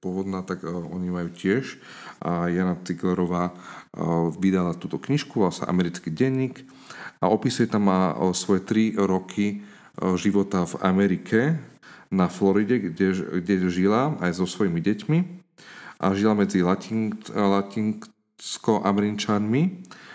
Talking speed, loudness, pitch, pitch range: 105 wpm, -24 LUFS, 100 Hz, 90-110 Hz